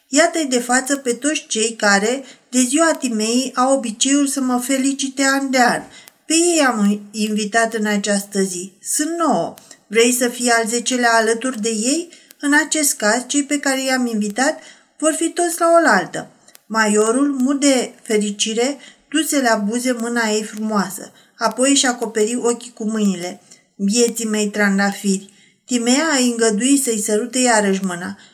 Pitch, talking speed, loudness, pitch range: 240 Hz, 155 wpm, -17 LUFS, 215-275 Hz